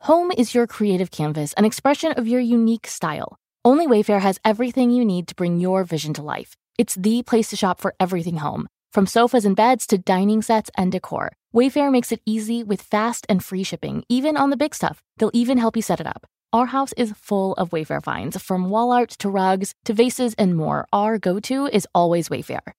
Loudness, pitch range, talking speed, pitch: -20 LUFS, 185-240 Hz, 220 wpm, 215 Hz